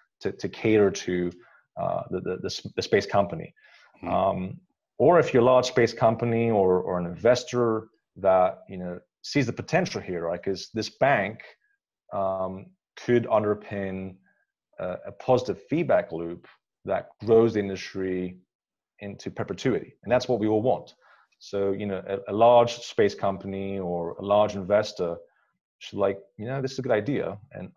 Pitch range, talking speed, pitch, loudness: 95-115 Hz, 160 wpm, 100 Hz, -26 LUFS